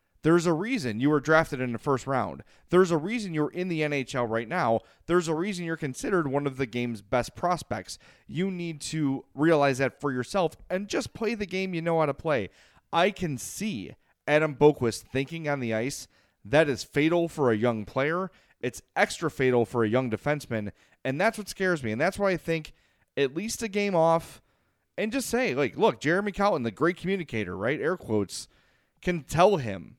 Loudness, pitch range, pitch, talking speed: -27 LUFS, 125-180 Hz, 150 Hz, 200 wpm